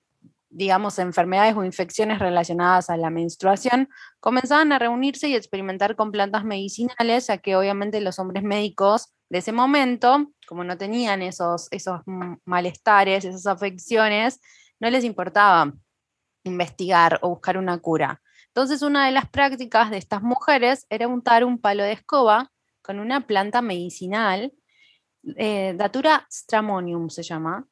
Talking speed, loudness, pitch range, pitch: 140 wpm, -21 LUFS, 185-245 Hz, 205 Hz